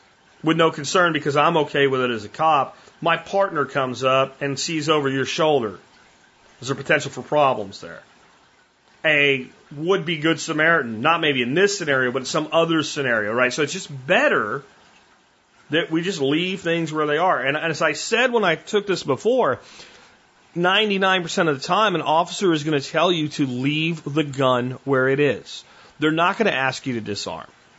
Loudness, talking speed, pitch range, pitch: -20 LUFS, 195 wpm, 140-170 Hz, 155 Hz